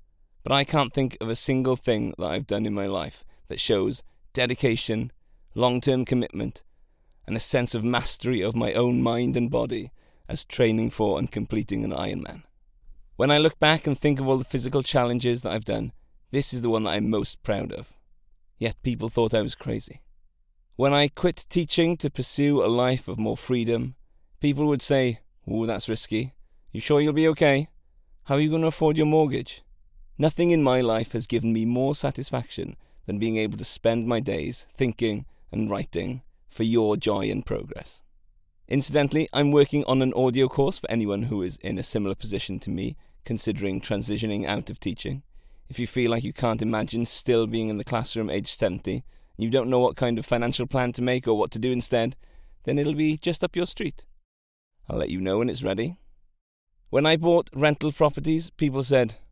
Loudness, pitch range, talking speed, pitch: -25 LUFS, 105-140 Hz, 195 wpm, 120 Hz